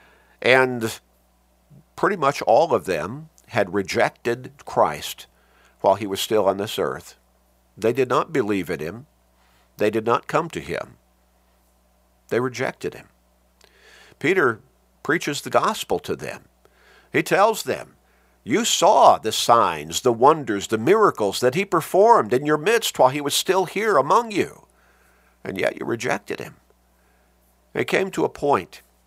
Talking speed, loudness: 145 wpm, -21 LUFS